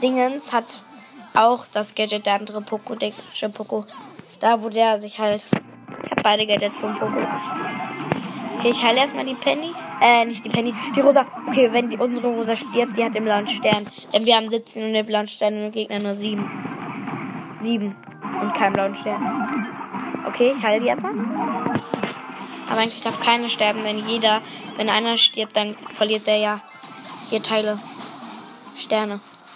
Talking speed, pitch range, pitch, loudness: 170 wpm, 210-240 Hz, 220 Hz, -21 LUFS